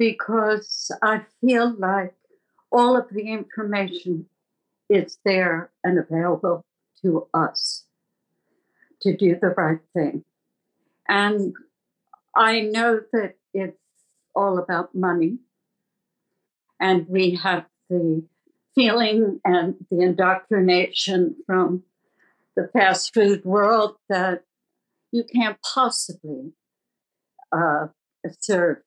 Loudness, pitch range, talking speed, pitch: -22 LUFS, 180-220 Hz, 95 wpm, 195 Hz